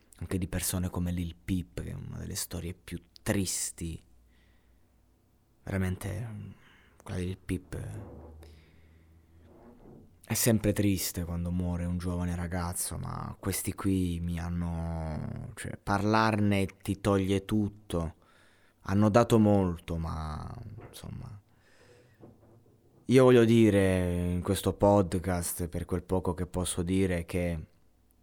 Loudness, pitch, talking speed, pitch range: -30 LUFS, 95 Hz, 115 wpm, 85-105 Hz